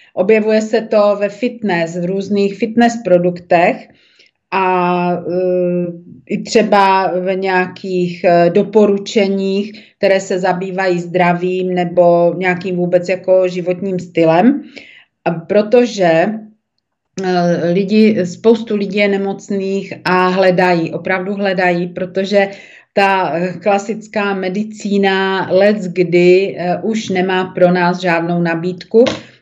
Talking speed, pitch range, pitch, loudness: 100 wpm, 180-205 Hz, 190 Hz, -14 LUFS